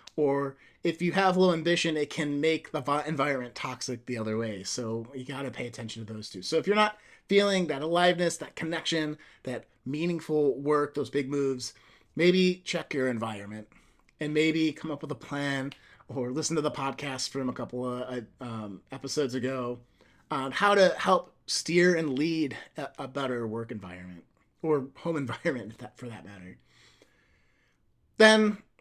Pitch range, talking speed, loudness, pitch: 125-160 Hz, 170 wpm, -29 LUFS, 140 Hz